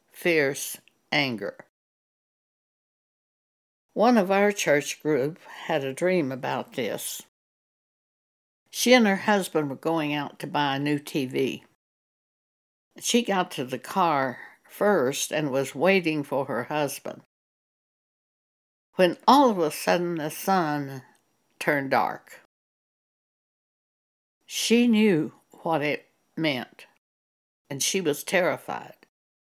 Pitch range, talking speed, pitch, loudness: 140-190 Hz, 110 wpm, 155 Hz, -25 LUFS